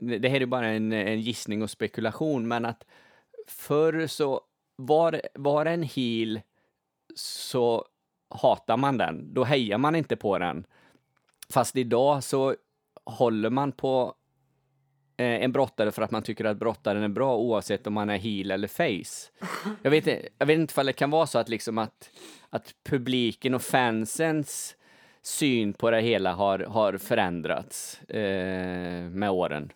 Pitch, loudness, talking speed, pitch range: 125 Hz, -27 LUFS, 155 wpm, 110-140 Hz